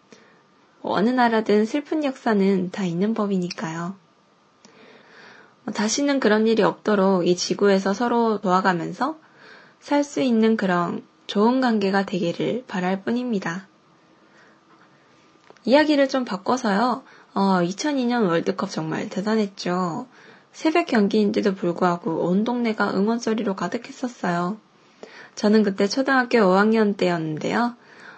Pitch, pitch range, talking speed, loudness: 210 Hz, 190-240 Hz, 260 characters per minute, -22 LUFS